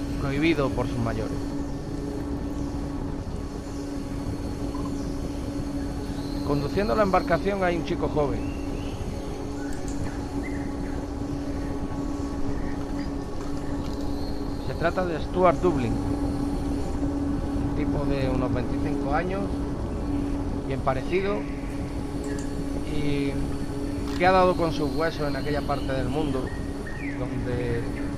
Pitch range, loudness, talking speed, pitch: 95-145 Hz, -28 LUFS, 80 wpm, 135 Hz